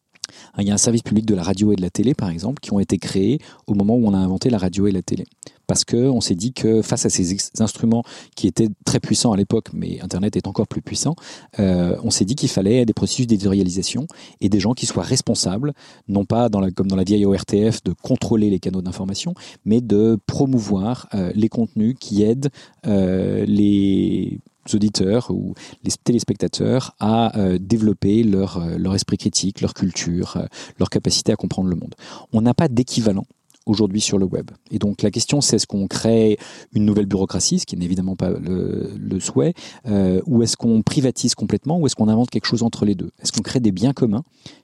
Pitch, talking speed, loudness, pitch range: 105 Hz, 215 wpm, -19 LUFS, 95-115 Hz